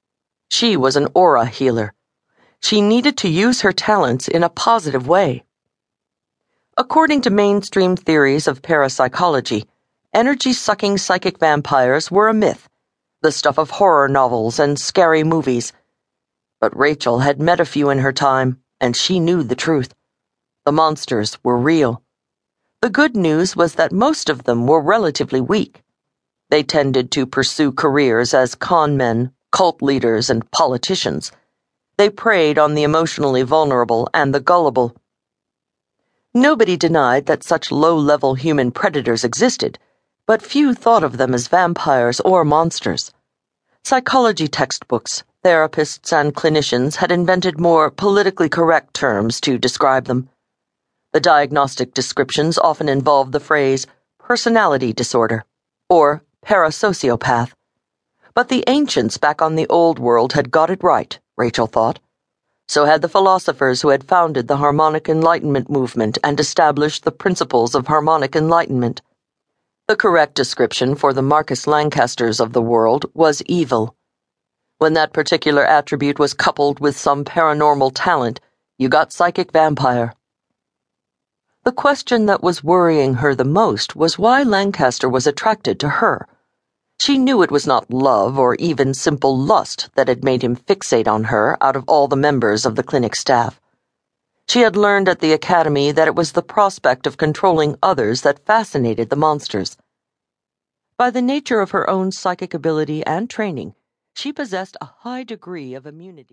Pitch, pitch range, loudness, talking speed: 150 Hz, 130-180 Hz, -16 LUFS, 150 wpm